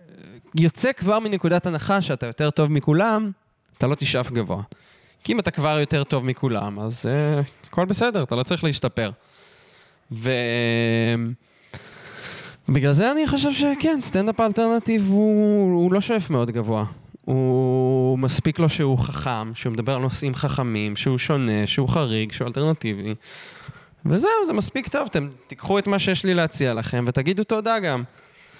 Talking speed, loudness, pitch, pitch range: 150 wpm, -22 LUFS, 145 Hz, 125-185 Hz